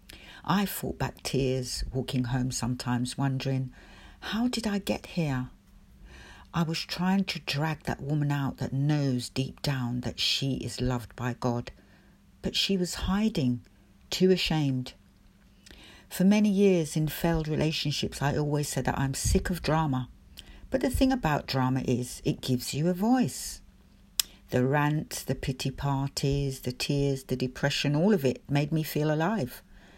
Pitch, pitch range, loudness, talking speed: 140 Hz, 125-160 Hz, -29 LUFS, 155 wpm